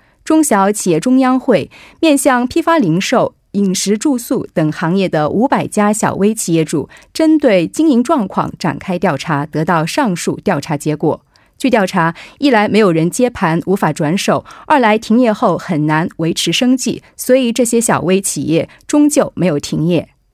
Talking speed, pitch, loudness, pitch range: 255 characters per minute, 205 Hz, -14 LUFS, 165-255 Hz